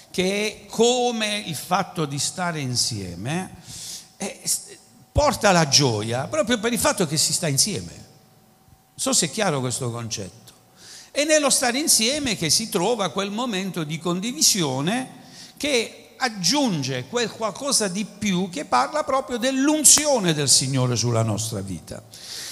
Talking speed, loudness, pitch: 140 wpm, -21 LUFS, 190 Hz